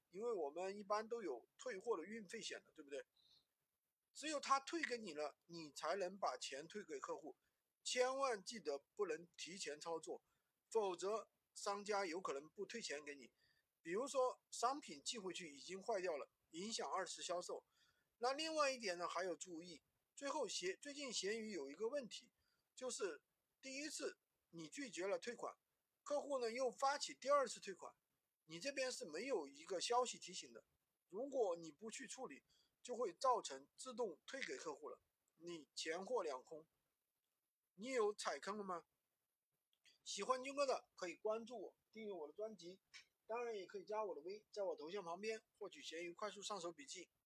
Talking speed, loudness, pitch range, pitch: 255 characters per minute, -47 LUFS, 180-285 Hz, 230 Hz